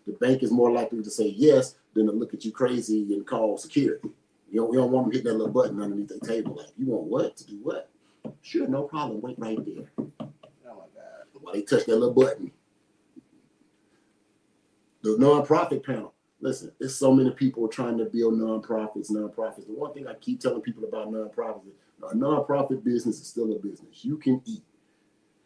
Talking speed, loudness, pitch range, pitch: 205 wpm, -26 LUFS, 110-130 Hz, 115 Hz